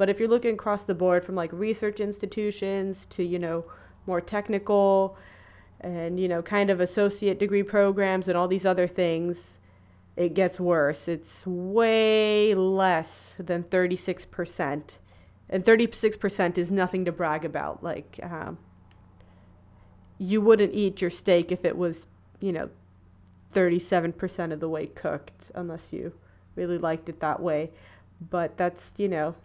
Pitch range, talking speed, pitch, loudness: 155-195 Hz, 145 wpm, 180 Hz, -26 LUFS